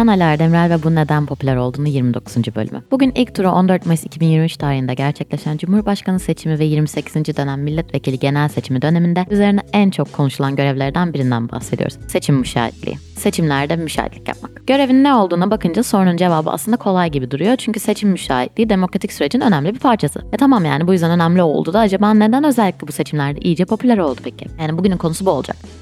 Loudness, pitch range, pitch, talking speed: -16 LUFS, 140-200 Hz, 165 Hz, 180 wpm